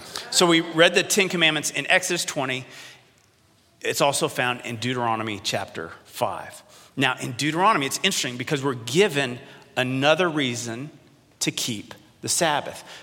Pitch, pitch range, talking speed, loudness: 145 Hz, 125-170 Hz, 140 wpm, -22 LUFS